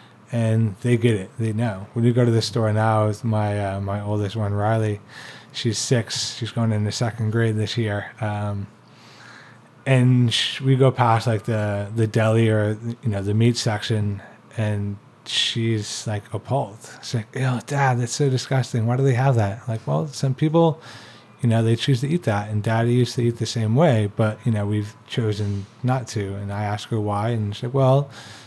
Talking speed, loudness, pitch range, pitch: 205 wpm, -22 LUFS, 105-125 Hz, 115 Hz